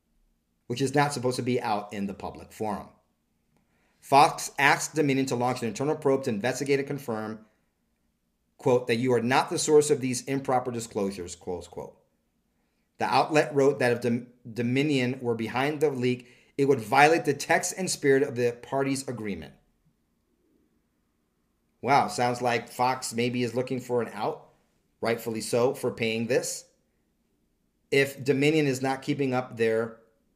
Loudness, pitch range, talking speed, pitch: -26 LUFS, 120-140 Hz, 155 wpm, 125 Hz